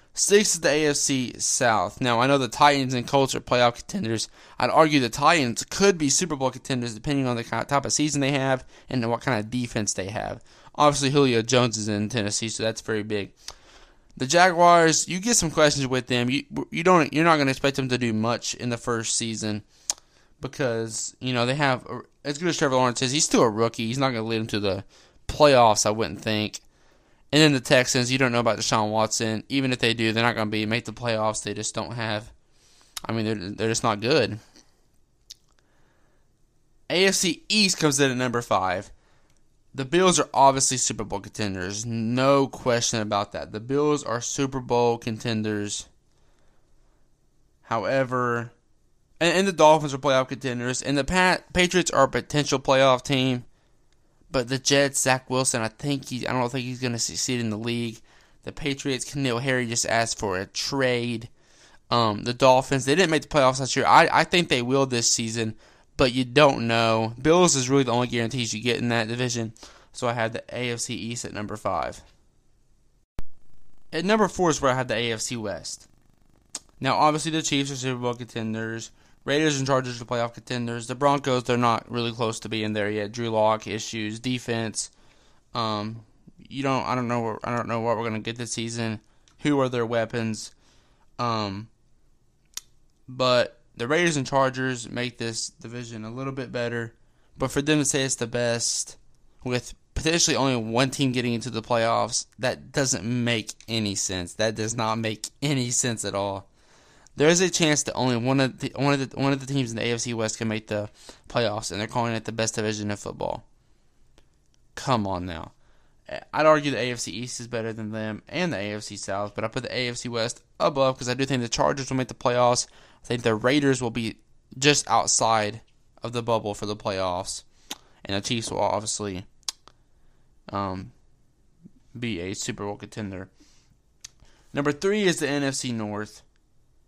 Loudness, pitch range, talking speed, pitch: -24 LUFS, 110-135 Hz, 190 wpm, 120 Hz